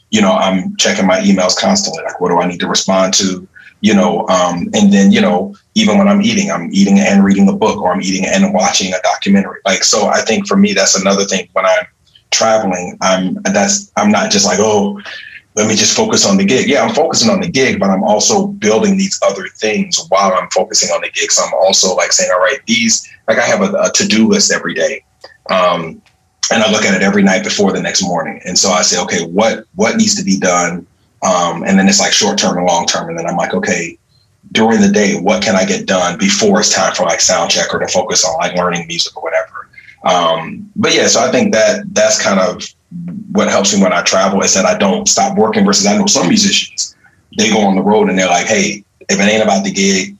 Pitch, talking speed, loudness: 195 Hz, 245 wpm, -11 LUFS